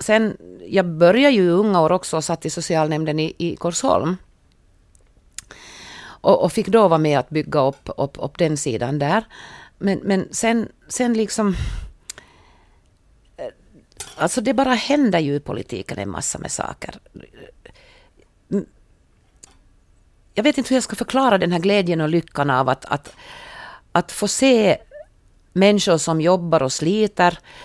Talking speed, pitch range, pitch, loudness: 150 wpm, 150-215 Hz, 175 Hz, -19 LUFS